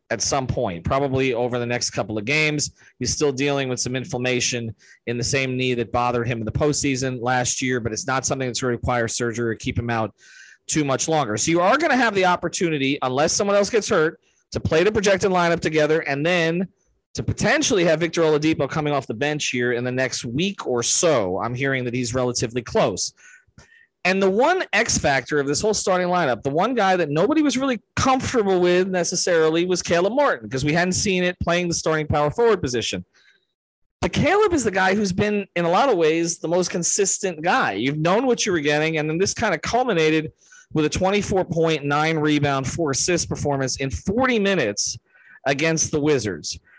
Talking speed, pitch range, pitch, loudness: 210 wpm, 130-180 Hz, 150 Hz, -21 LUFS